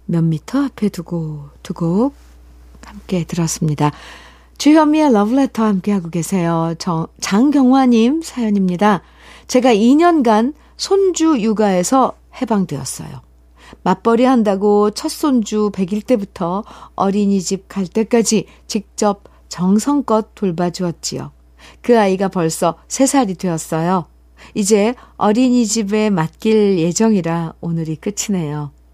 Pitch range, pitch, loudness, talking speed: 170-230 Hz, 200 Hz, -16 LUFS, 250 characters per minute